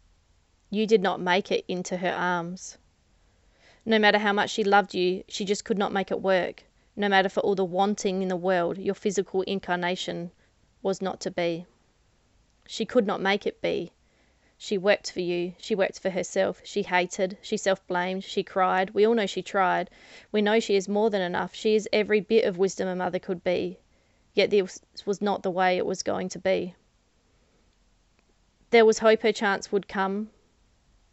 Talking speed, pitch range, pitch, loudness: 190 wpm, 180-205 Hz, 190 Hz, -26 LUFS